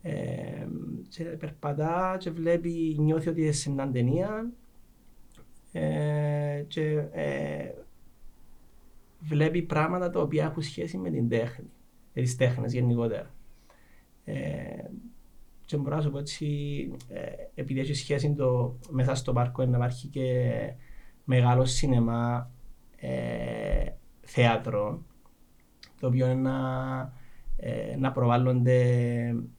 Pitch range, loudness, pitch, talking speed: 125-155 Hz, -29 LUFS, 130 Hz, 110 wpm